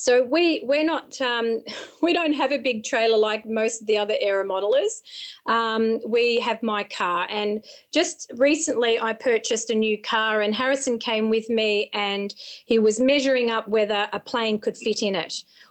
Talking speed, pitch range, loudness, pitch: 185 wpm, 215-265 Hz, -23 LUFS, 230 Hz